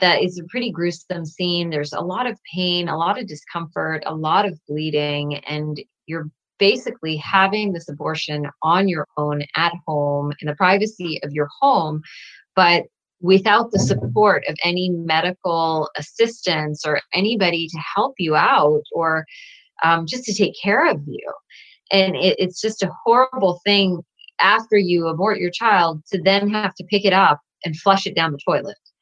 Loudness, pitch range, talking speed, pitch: -19 LUFS, 155-195 Hz, 170 wpm, 175 Hz